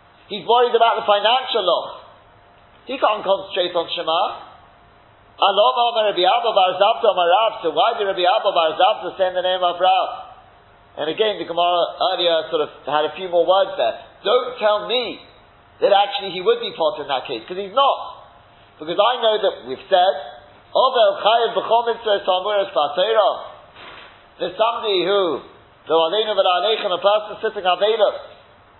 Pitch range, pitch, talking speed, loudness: 175-225 Hz, 200 Hz, 140 wpm, -19 LUFS